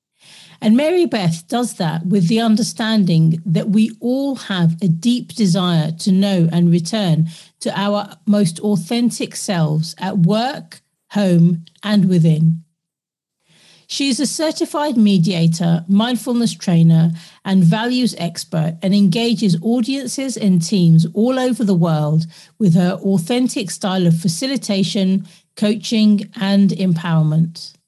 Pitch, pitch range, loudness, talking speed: 195 Hz, 170-220 Hz, -17 LUFS, 125 wpm